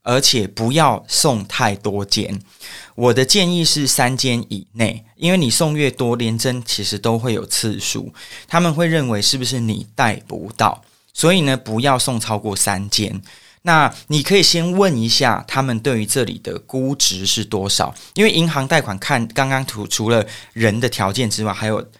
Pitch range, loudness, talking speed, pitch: 110-140 Hz, -17 LUFS, 260 characters per minute, 120 Hz